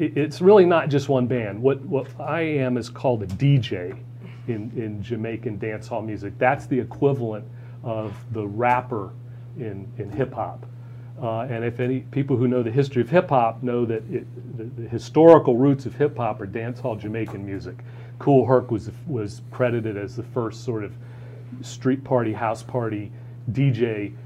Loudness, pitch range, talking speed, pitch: -23 LUFS, 115-130 Hz, 175 wpm, 120 Hz